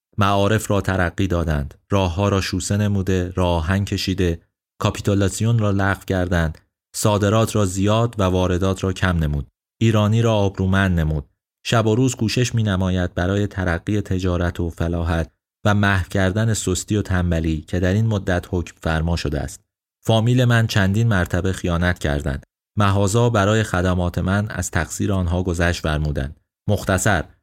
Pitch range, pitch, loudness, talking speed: 90-105 Hz, 95 Hz, -20 LUFS, 150 wpm